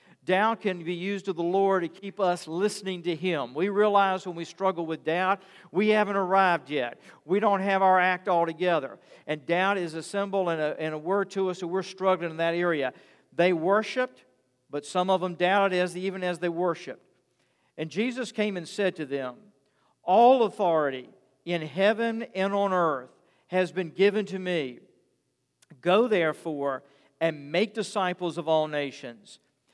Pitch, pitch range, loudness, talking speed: 180 Hz, 165-195 Hz, -27 LUFS, 180 wpm